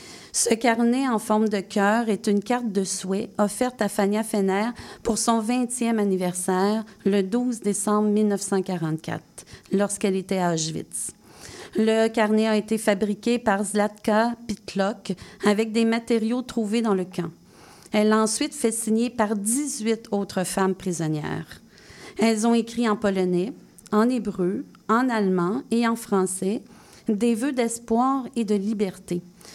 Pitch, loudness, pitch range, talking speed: 215 Hz, -24 LUFS, 195-230 Hz, 140 wpm